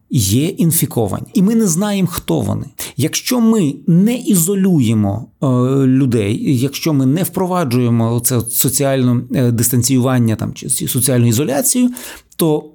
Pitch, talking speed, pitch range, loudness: 135 Hz, 120 wpm, 120-175 Hz, -15 LUFS